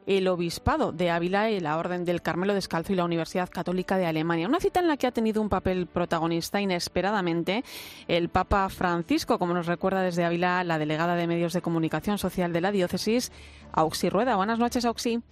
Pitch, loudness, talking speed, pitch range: 180 Hz, -27 LUFS, 195 wpm, 170-205 Hz